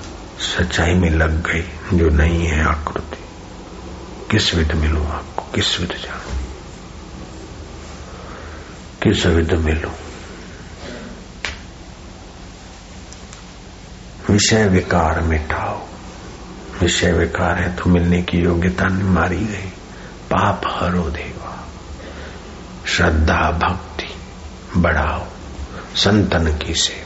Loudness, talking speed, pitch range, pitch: -18 LUFS, 85 wpm, 80-90 Hz, 85 Hz